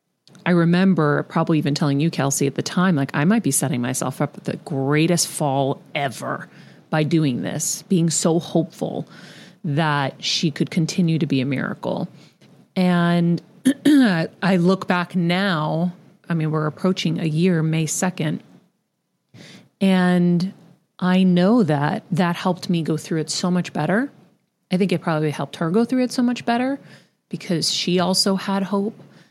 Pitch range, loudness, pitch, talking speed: 155-190 Hz, -20 LUFS, 175 Hz, 160 wpm